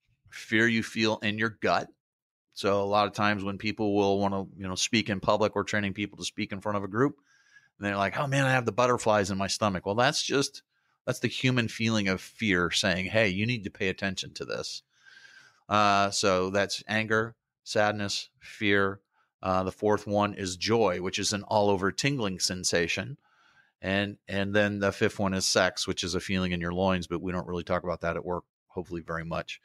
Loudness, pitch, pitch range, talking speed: -28 LUFS, 100 Hz, 95-110 Hz, 215 wpm